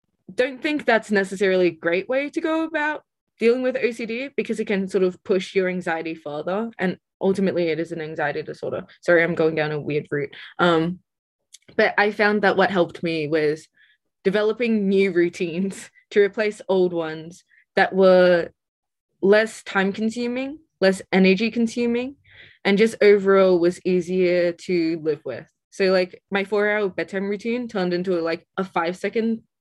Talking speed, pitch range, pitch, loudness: 165 wpm, 175-220 Hz, 190 Hz, -22 LUFS